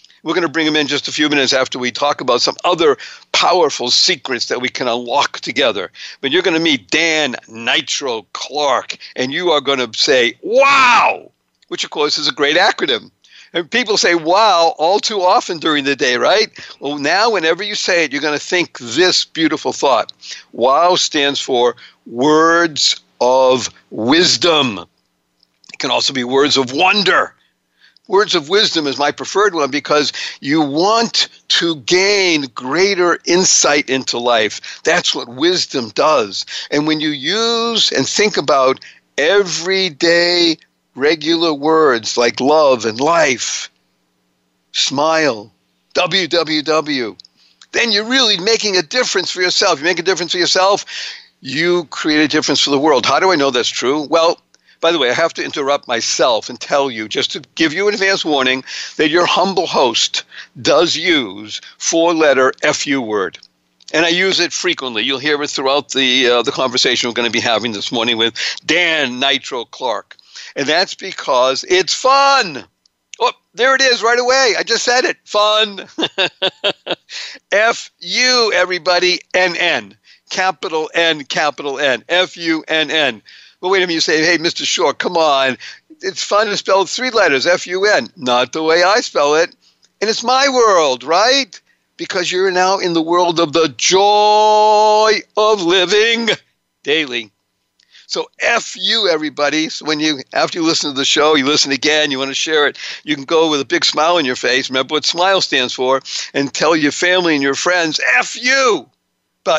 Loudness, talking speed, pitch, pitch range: -14 LUFS, 175 wpm, 165 Hz, 140-190 Hz